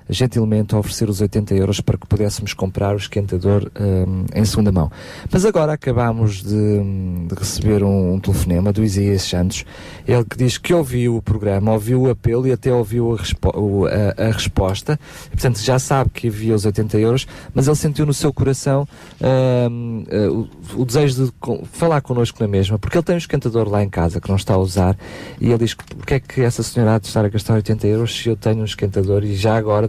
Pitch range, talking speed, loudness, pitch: 100-125 Hz, 210 wpm, -18 LUFS, 110 Hz